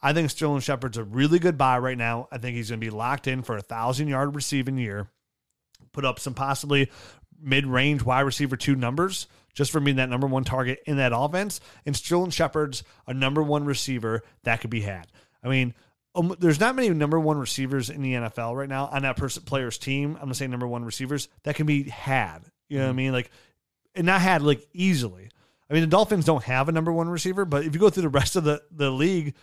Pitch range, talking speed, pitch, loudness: 125-150 Hz, 240 wpm, 135 Hz, -25 LUFS